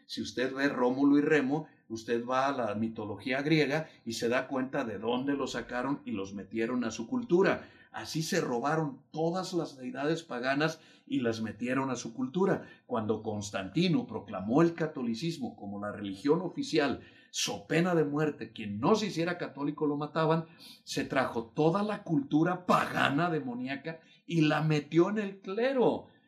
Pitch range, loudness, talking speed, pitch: 125-165 Hz, -31 LUFS, 165 wpm, 150 Hz